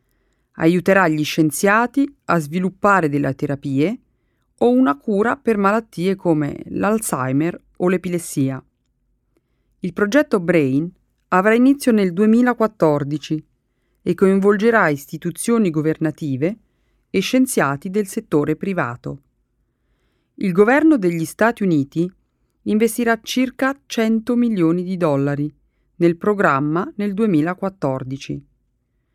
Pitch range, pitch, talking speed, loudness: 150-220 Hz, 180 Hz, 95 wpm, -18 LUFS